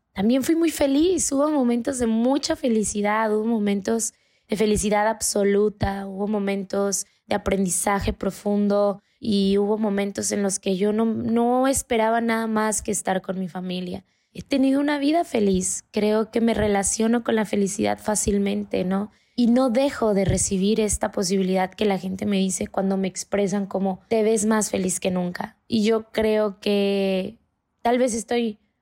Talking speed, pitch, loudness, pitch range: 165 wpm, 210 Hz, -23 LUFS, 195-230 Hz